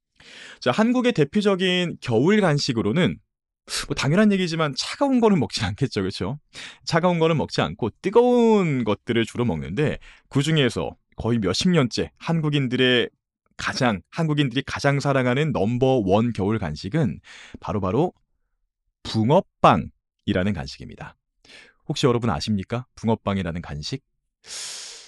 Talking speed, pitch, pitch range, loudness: 300 characters per minute, 135 Hz, 115-165 Hz, -22 LUFS